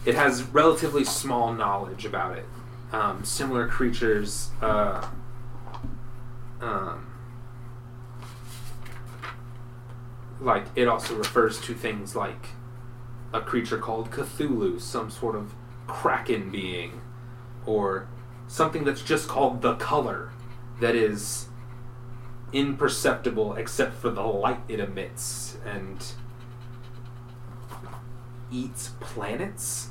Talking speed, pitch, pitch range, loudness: 95 wpm, 120 Hz, 115-125 Hz, -27 LUFS